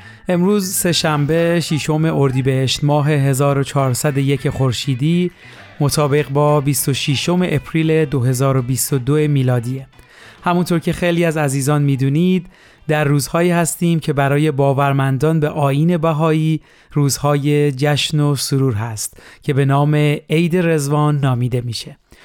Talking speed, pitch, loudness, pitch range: 110 wpm, 145 Hz, -16 LUFS, 140-160 Hz